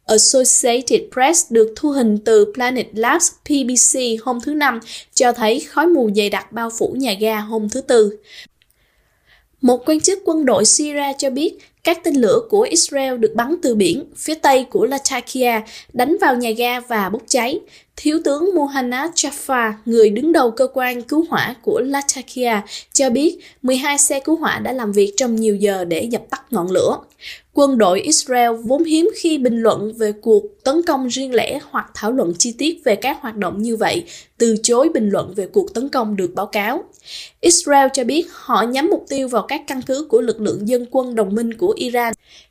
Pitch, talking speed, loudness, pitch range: 255 Hz, 195 wpm, -17 LUFS, 225-300 Hz